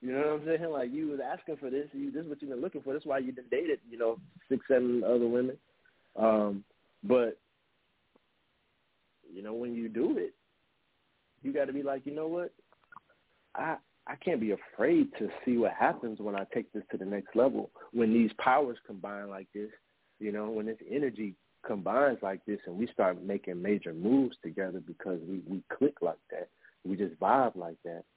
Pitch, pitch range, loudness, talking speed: 115 Hz, 100-140 Hz, -32 LUFS, 200 wpm